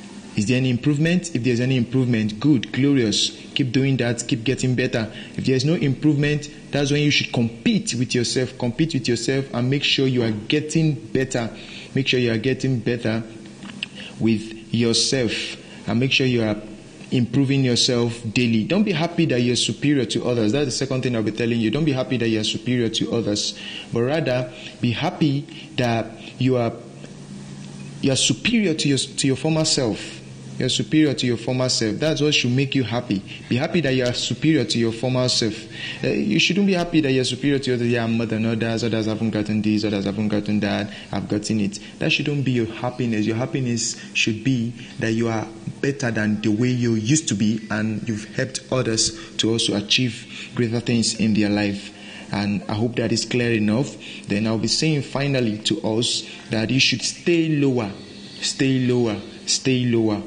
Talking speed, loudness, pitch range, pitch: 195 wpm, -21 LUFS, 110-135 Hz, 120 Hz